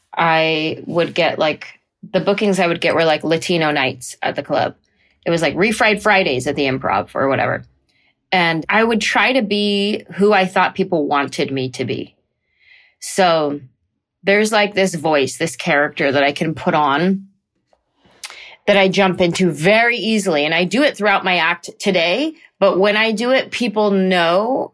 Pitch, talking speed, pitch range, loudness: 185 Hz, 175 wpm, 160-205 Hz, -16 LUFS